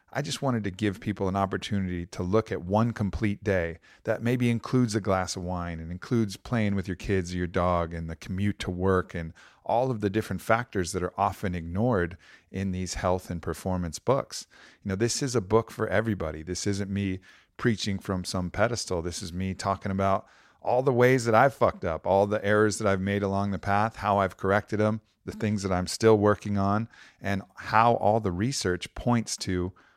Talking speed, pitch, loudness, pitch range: 210 wpm, 100 Hz, -27 LUFS, 90-110 Hz